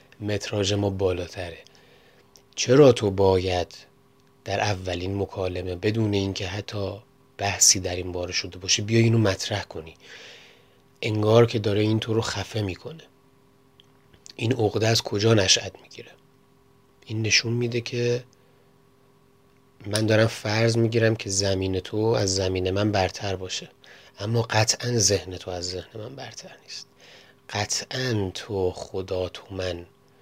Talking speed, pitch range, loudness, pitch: 130 wpm, 95-120 Hz, -24 LUFS, 105 Hz